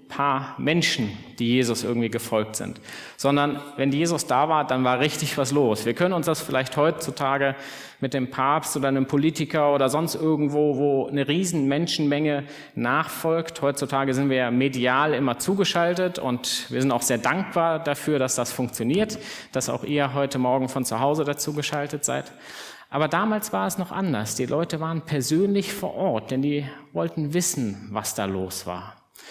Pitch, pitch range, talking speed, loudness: 140 Hz, 130-155 Hz, 170 wpm, -24 LUFS